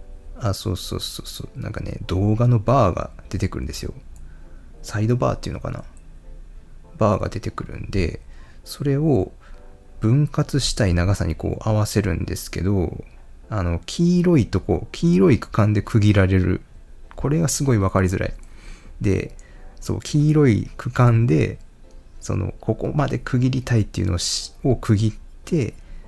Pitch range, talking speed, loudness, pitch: 90-125 Hz, 280 characters per minute, -21 LUFS, 105 Hz